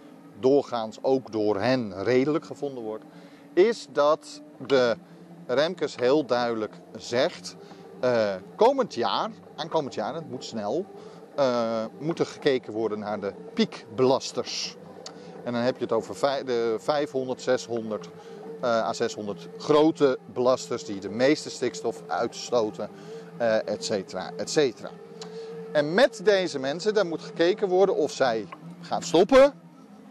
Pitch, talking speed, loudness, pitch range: 135 Hz, 135 wpm, -26 LUFS, 115-160 Hz